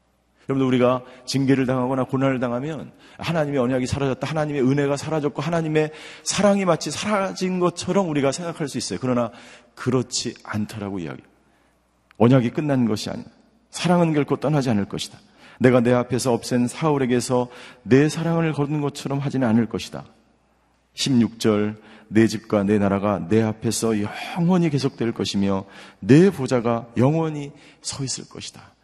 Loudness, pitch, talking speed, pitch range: -22 LUFS, 130 Hz, 350 characters per minute, 115-150 Hz